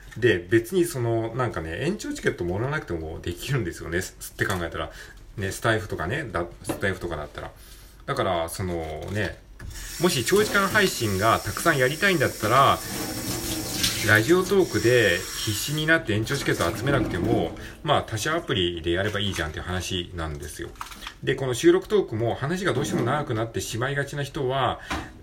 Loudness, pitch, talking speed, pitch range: -24 LUFS, 110 Hz, 385 characters per minute, 95-150 Hz